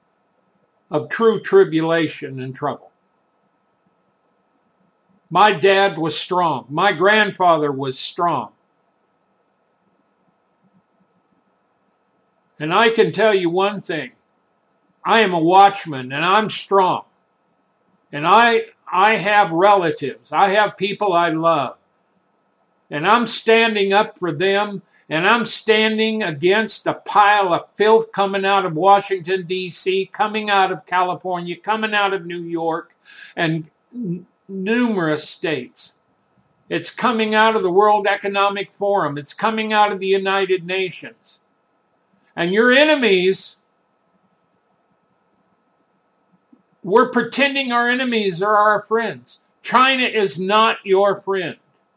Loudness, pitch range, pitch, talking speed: -17 LUFS, 180-215 Hz, 195 Hz, 115 wpm